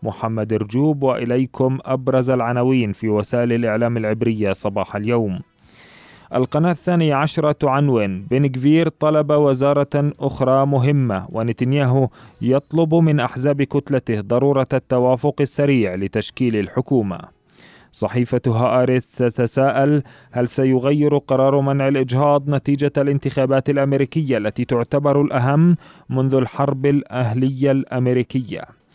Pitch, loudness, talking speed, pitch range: 130 Hz, -18 LUFS, 100 wpm, 120-140 Hz